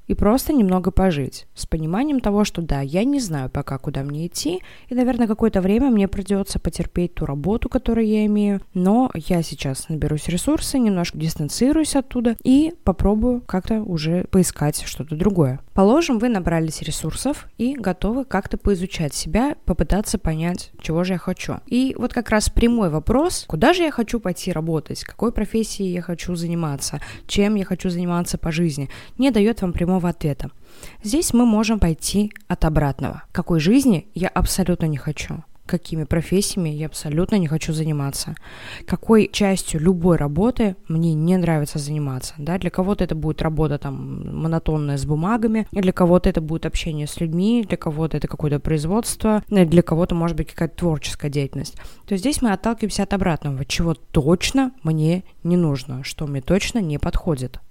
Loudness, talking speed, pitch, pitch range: -21 LUFS, 165 wpm, 180 Hz, 160-215 Hz